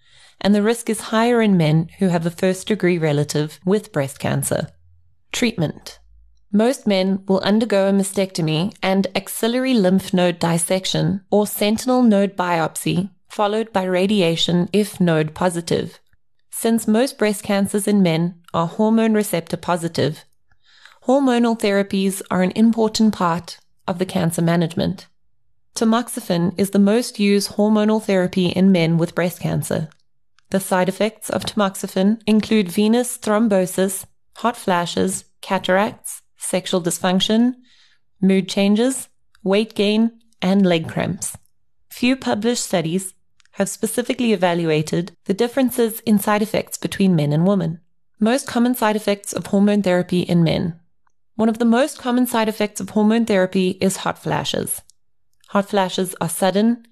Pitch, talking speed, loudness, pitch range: 195 Hz, 140 wpm, -19 LUFS, 175-215 Hz